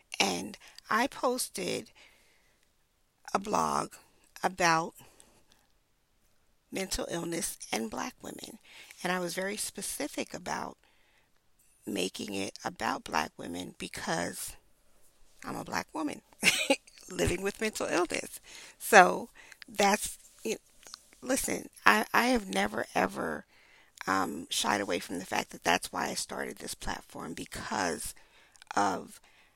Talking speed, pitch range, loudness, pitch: 115 wpm, 185-250 Hz, -31 LUFS, 200 Hz